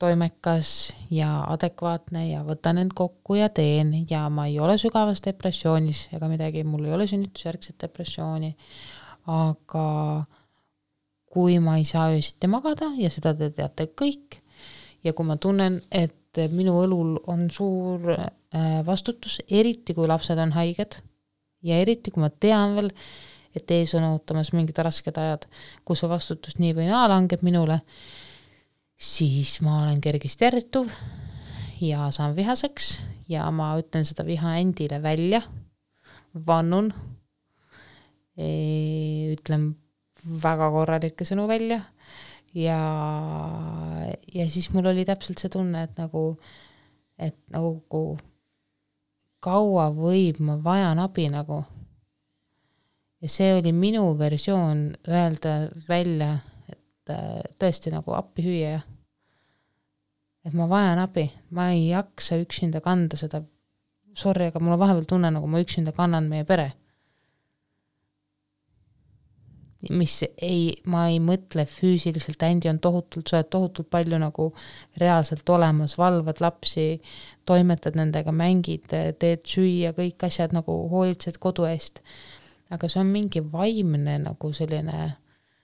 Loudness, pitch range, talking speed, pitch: -25 LUFS, 150-180 Hz, 125 wpm, 165 Hz